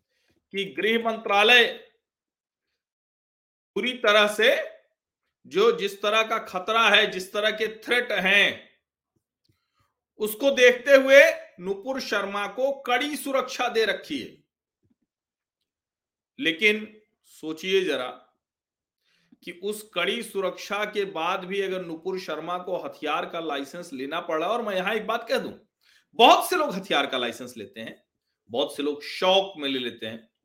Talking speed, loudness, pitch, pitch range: 135 wpm, -23 LUFS, 210 Hz, 185-245 Hz